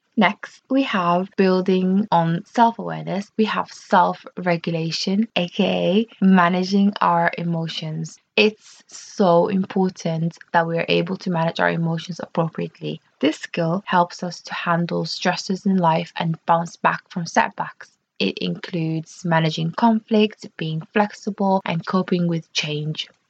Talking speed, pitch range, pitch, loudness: 130 wpm, 165-195 Hz, 175 Hz, -21 LUFS